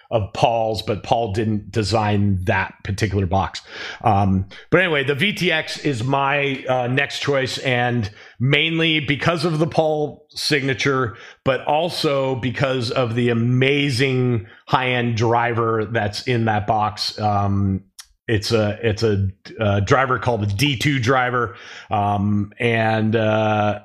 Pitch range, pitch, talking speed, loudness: 105-140 Hz, 120 Hz, 130 wpm, -20 LUFS